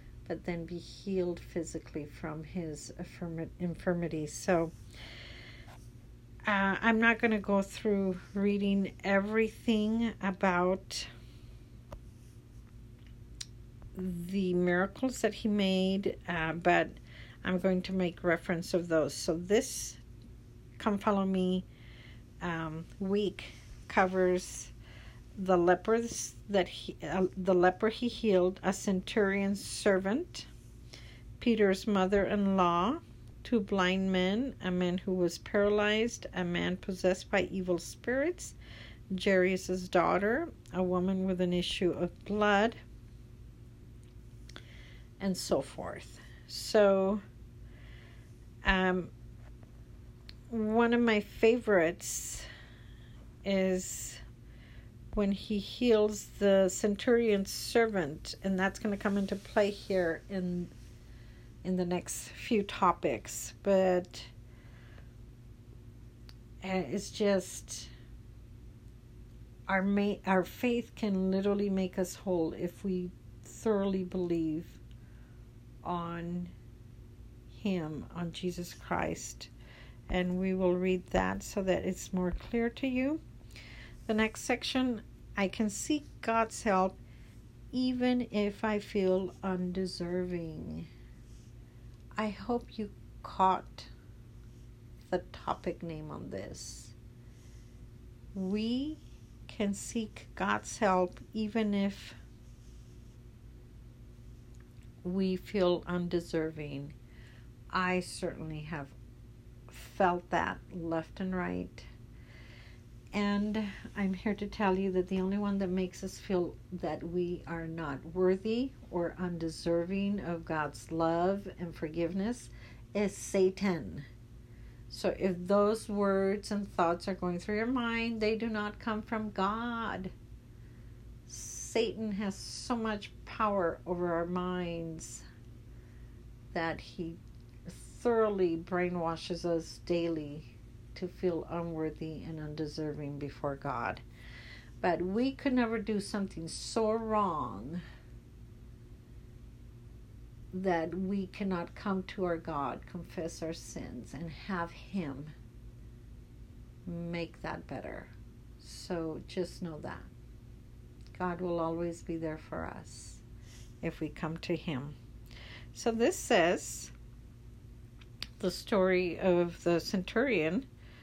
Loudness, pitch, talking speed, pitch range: -33 LUFS, 175 Hz, 105 wpm, 120-195 Hz